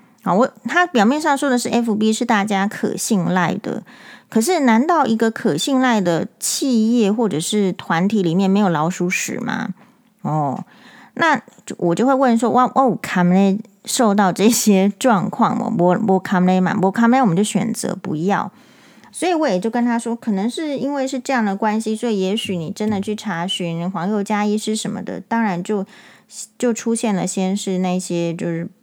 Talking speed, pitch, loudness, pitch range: 260 characters per minute, 215 Hz, -18 LUFS, 190-240 Hz